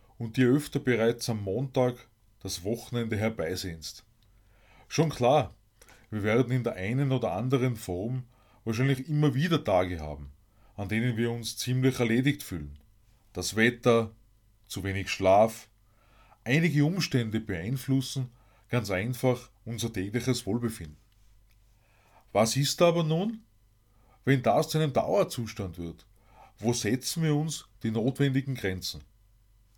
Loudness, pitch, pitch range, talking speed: -28 LUFS, 115 Hz, 105-130 Hz, 125 wpm